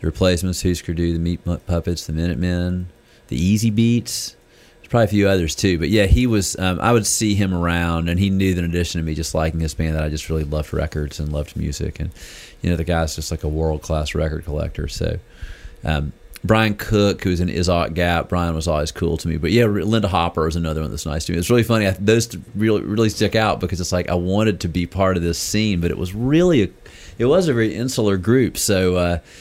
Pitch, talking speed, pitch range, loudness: 90 Hz, 245 wpm, 80-105 Hz, -20 LUFS